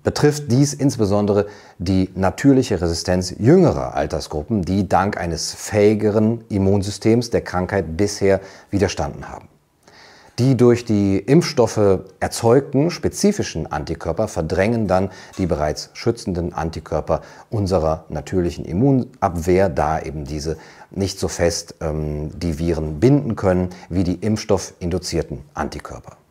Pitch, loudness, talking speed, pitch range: 95 Hz, -20 LUFS, 110 wpm, 85-110 Hz